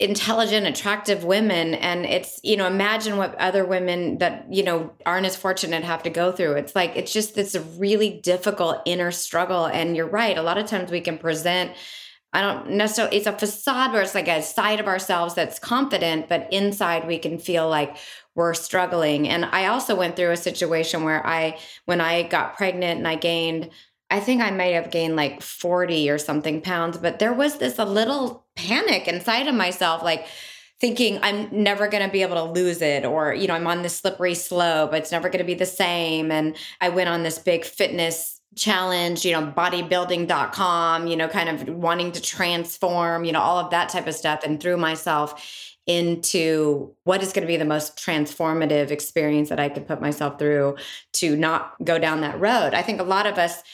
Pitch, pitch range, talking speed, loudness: 175 Hz, 165-195 Hz, 205 wpm, -22 LUFS